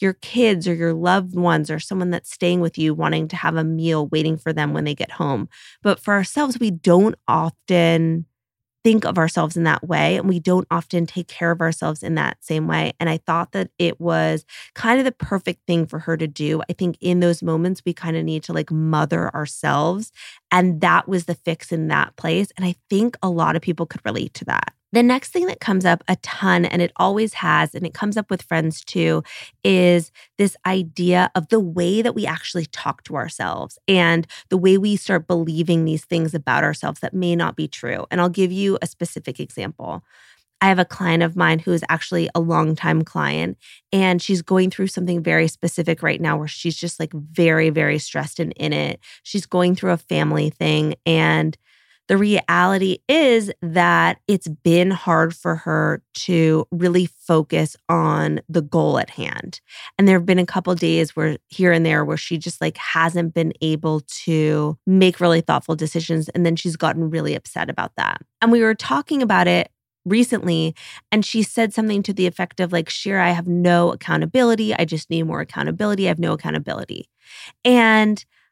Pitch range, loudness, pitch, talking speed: 160-185 Hz, -19 LUFS, 170 Hz, 205 wpm